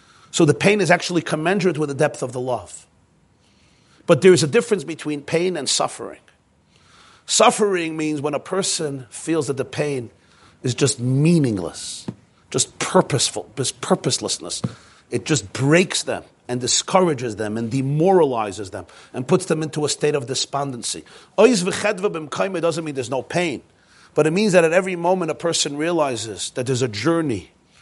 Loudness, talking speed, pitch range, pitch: -20 LUFS, 160 wpm, 130-175 Hz, 155 Hz